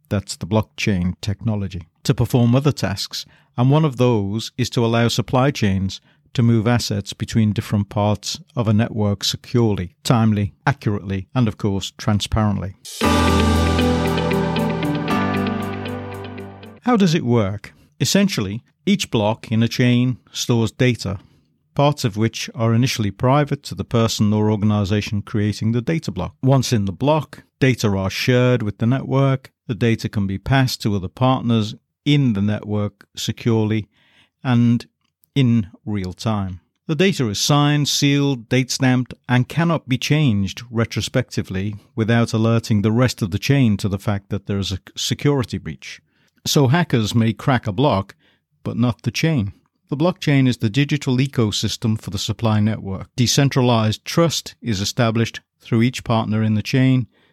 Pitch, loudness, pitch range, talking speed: 115 Hz, -19 LUFS, 105-130 Hz, 150 wpm